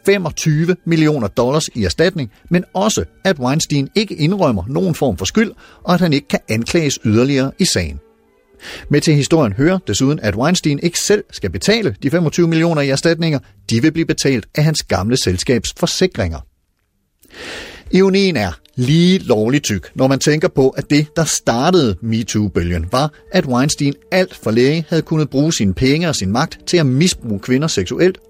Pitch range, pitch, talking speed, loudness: 115-175 Hz, 145 Hz, 175 wpm, -16 LUFS